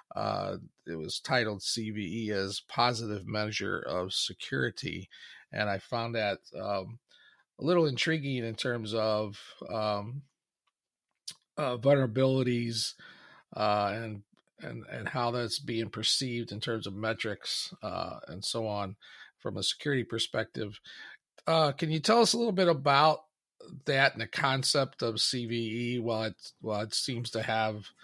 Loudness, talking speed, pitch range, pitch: -31 LUFS, 140 wpm, 105-130 Hz, 115 Hz